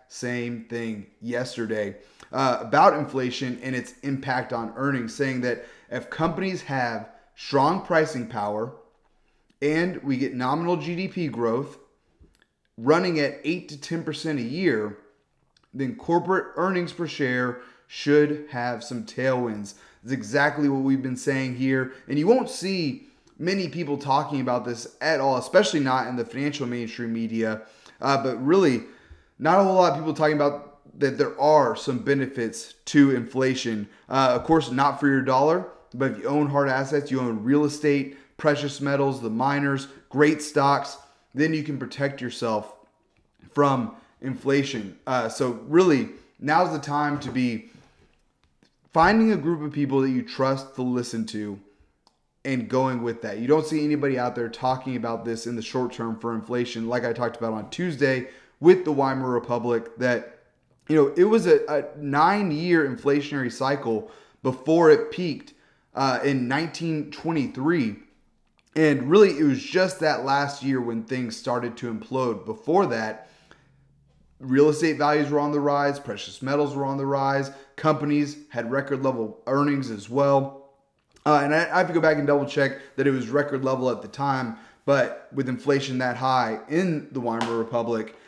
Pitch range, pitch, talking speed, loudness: 125-150 Hz, 135 Hz, 160 wpm, -24 LUFS